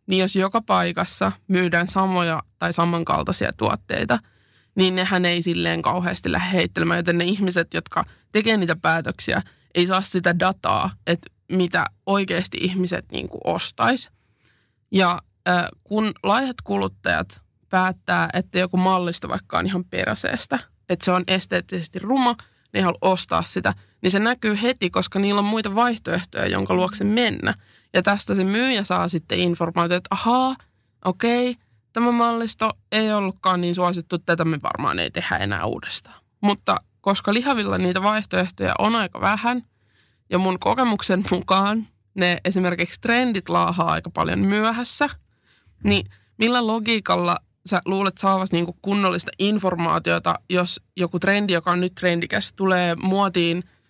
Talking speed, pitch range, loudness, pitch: 140 wpm, 170-205 Hz, -22 LUFS, 185 Hz